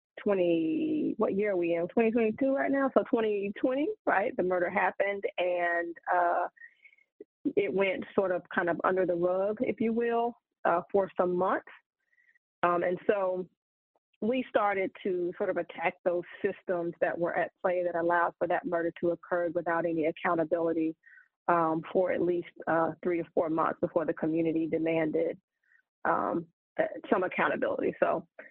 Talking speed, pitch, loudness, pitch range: 160 wpm, 180 Hz, -30 LUFS, 170-230 Hz